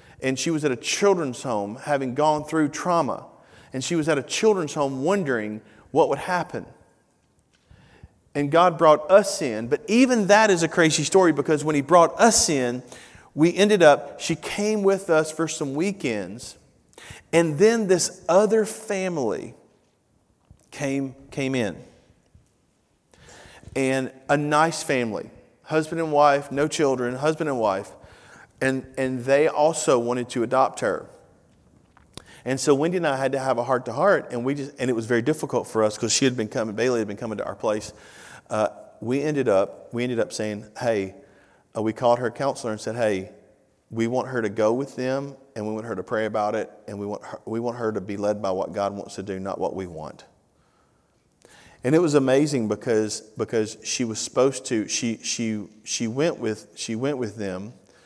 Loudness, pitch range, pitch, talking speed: -23 LUFS, 110-155 Hz, 135 Hz, 185 wpm